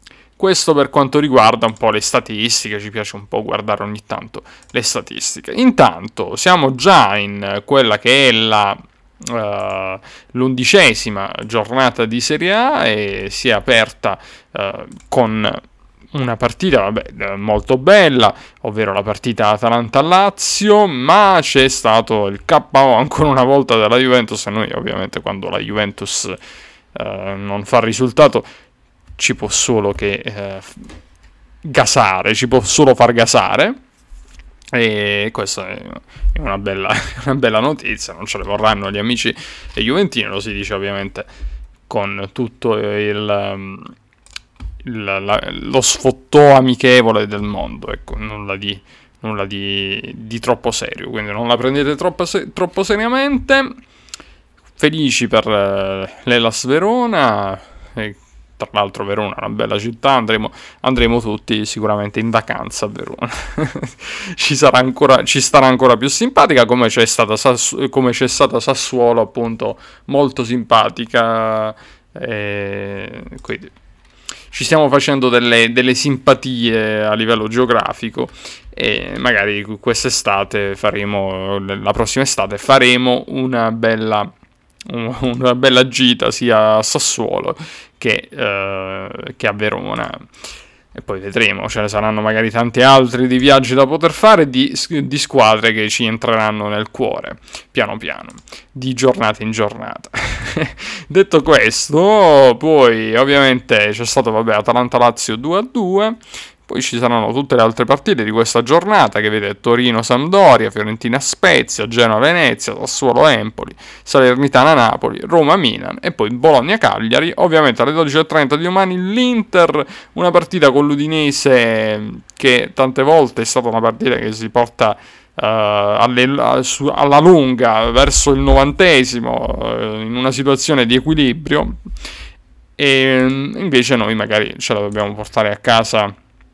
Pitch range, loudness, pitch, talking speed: 105-135 Hz, -14 LUFS, 120 Hz, 130 wpm